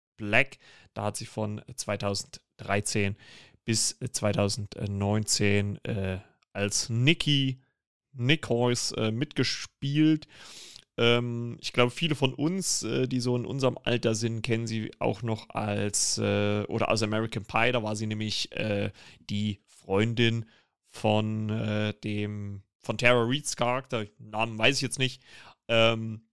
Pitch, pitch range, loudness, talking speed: 110 Hz, 105-125 Hz, -28 LUFS, 130 wpm